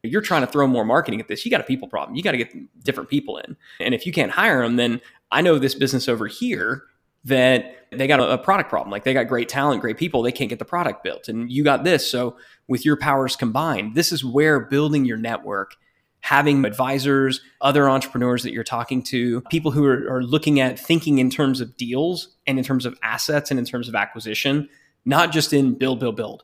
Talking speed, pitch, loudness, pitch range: 235 wpm, 130 Hz, -21 LUFS, 125-145 Hz